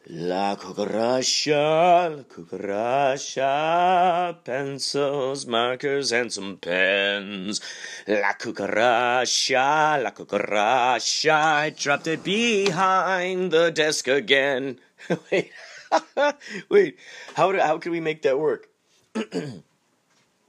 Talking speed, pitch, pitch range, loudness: 90 wpm, 155 Hz, 130-180 Hz, -22 LUFS